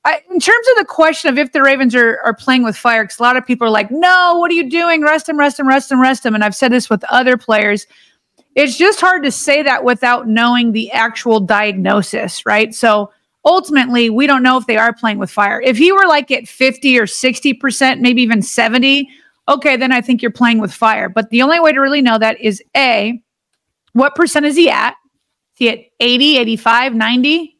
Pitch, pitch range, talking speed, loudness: 255 Hz, 230-285 Hz, 230 wpm, -12 LUFS